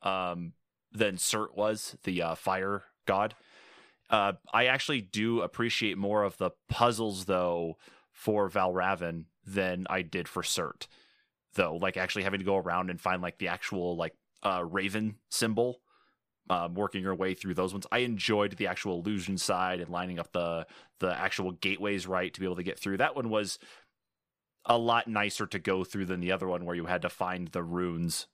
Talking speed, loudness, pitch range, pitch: 185 wpm, -31 LUFS, 90-105 Hz, 95 Hz